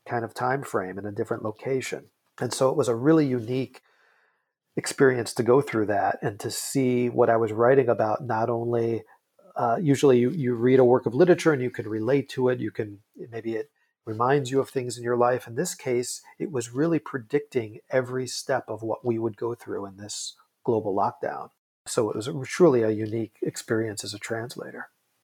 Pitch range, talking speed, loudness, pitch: 115-130 Hz, 205 wpm, -25 LUFS, 120 Hz